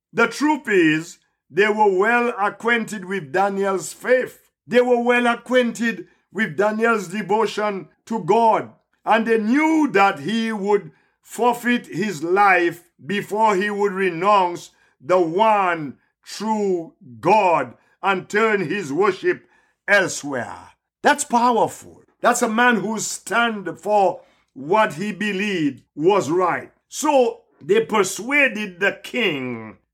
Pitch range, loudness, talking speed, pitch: 195-240 Hz, -20 LUFS, 120 wpm, 215 Hz